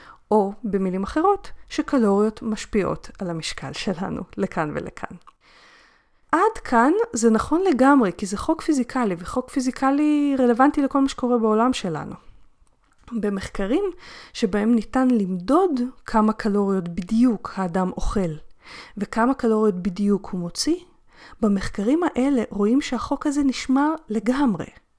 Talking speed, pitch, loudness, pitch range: 115 wpm, 235 Hz, -22 LUFS, 205-275 Hz